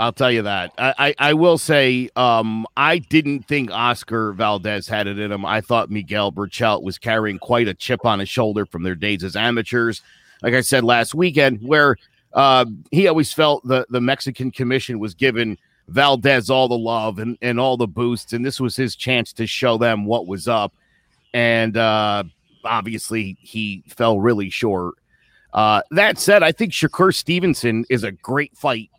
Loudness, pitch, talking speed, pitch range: -18 LUFS, 120 Hz, 185 wpm, 110-135 Hz